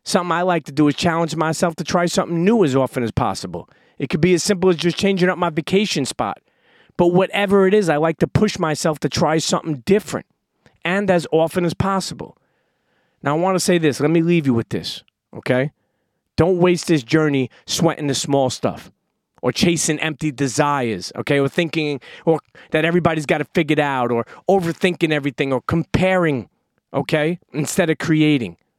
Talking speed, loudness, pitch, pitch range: 190 wpm, -19 LUFS, 165 Hz, 145-180 Hz